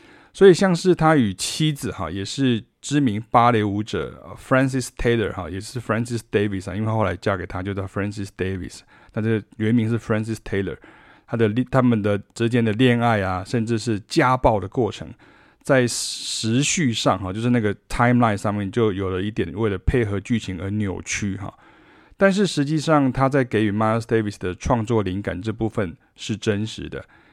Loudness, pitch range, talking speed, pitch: -21 LUFS, 100-125 Hz, 370 characters per minute, 110 Hz